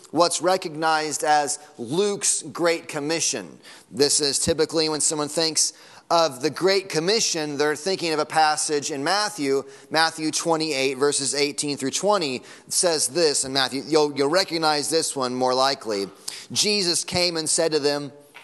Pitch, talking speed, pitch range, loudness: 155 Hz, 150 wpm, 145-165 Hz, -22 LUFS